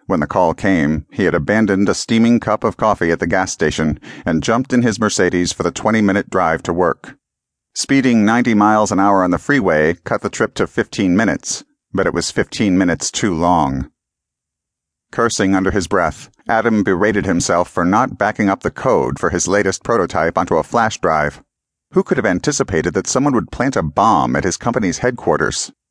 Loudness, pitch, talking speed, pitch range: -16 LUFS, 105 Hz, 195 wpm, 95-115 Hz